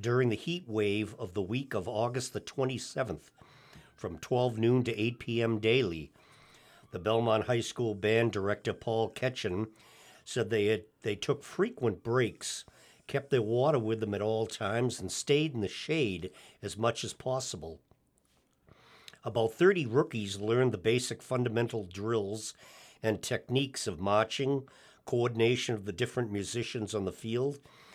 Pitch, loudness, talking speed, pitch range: 115 Hz, -32 LUFS, 150 wpm, 110-125 Hz